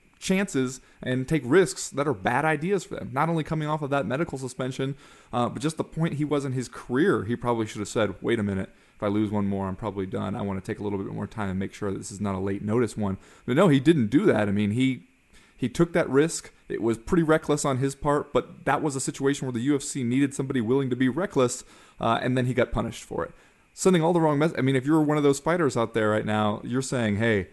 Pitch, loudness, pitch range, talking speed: 130 Hz, -26 LUFS, 110-150 Hz, 275 wpm